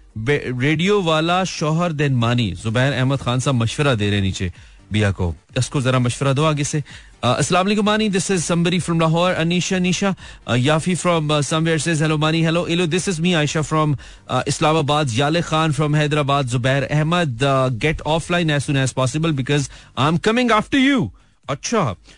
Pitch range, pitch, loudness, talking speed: 130-170 Hz, 150 Hz, -19 LUFS, 160 wpm